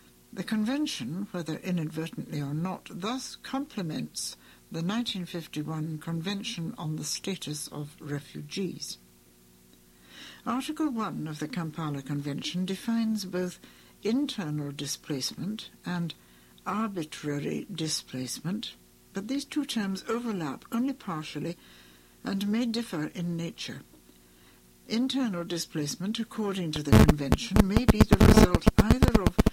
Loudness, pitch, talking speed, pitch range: -29 LUFS, 170 Hz, 110 wpm, 145-210 Hz